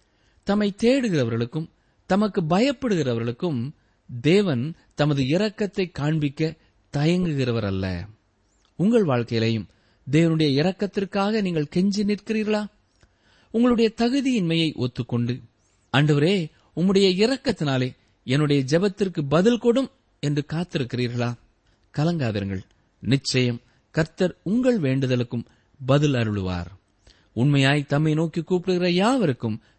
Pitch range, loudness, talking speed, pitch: 120-190 Hz, -23 LUFS, 80 wpm, 145 Hz